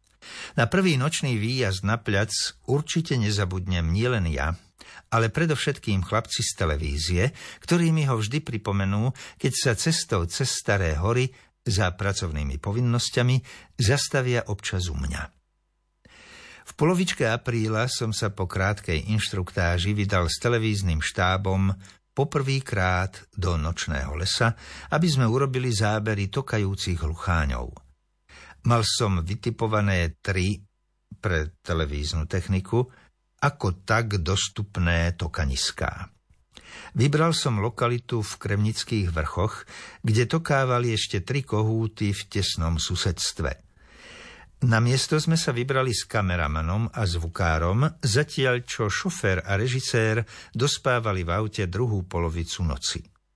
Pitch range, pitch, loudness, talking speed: 90-125 Hz, 105 Hz, -25 LUFS, 110 wpm